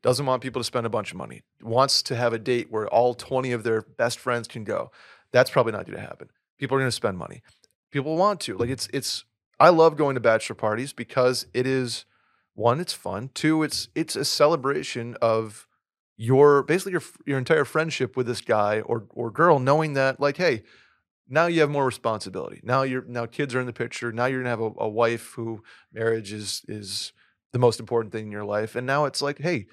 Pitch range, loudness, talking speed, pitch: 115-140 Hz, -24 LUFS, 220 wpm, 125 Hz